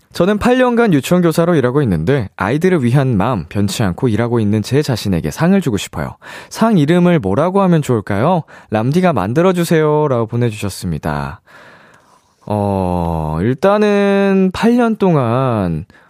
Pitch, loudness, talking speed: 135 Hz, -14 LUFS, 310 characters per minute